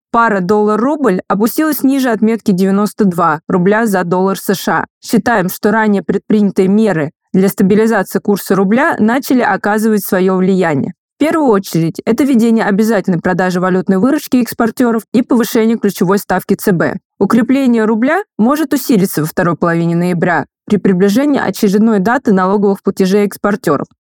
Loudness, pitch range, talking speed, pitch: -12 LUFS, 195-230 Hz, 130 wpm, 210 Hz